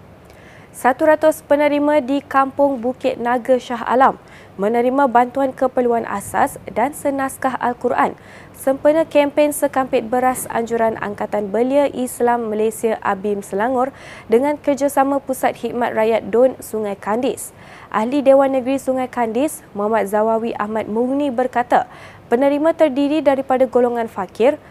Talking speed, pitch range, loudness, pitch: 120 wpm, 230-280 Hz, -18 LUFS, 255 Hz